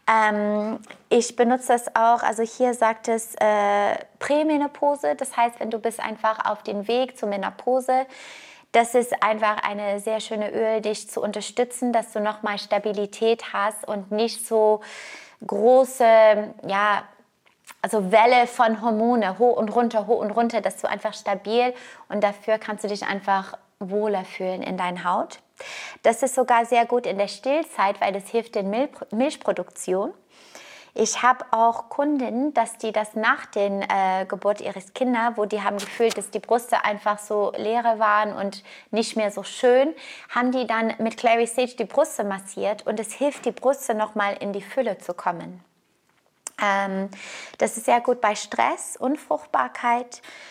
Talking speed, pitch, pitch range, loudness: 165 wpm, 220 Hz, 205-245 Hz, -23 LUFS